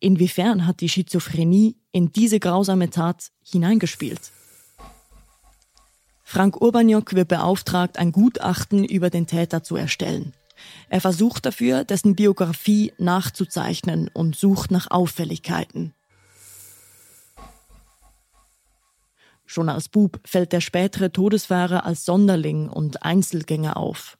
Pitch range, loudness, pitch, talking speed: 165-195 Hz, -21 LUFS, 180 Hz, 105 wpm